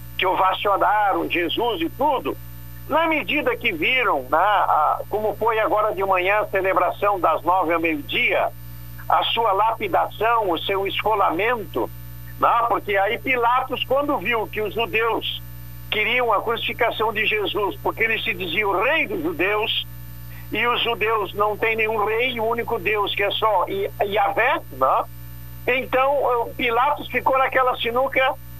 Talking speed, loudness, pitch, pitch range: 140 wpm, -21 LUFS, 215 Hz, 170-240 Hz